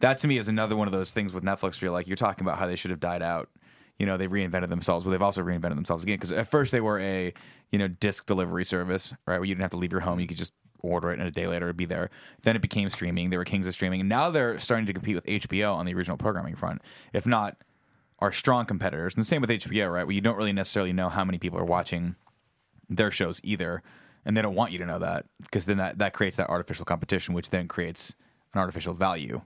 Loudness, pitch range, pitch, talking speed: -28 LUFS, 90-105 Hz, 95 Hz, 275 wpm